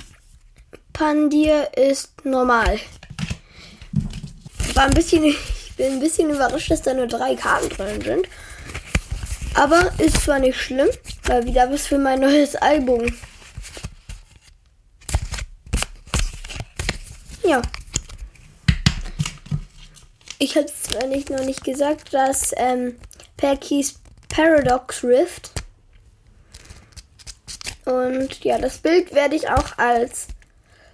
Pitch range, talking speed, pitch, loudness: 260-300 Hz, 100 wpm, 275 Hz, -20 LUFS